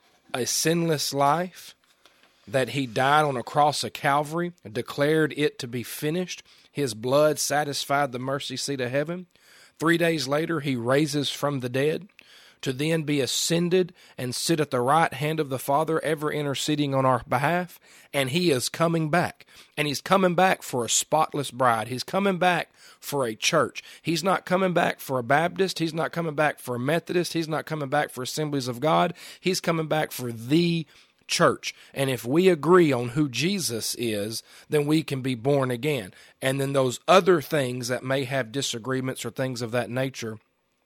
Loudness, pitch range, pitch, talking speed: -25 LUFS, 130-165 Hz, 145 Hz, 185 wpm